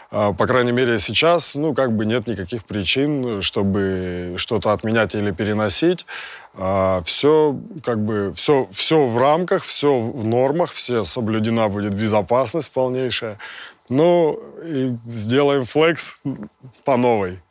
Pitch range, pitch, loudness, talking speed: 105-140 Hz, 120 Hz, -19 LUFS, 125 wpm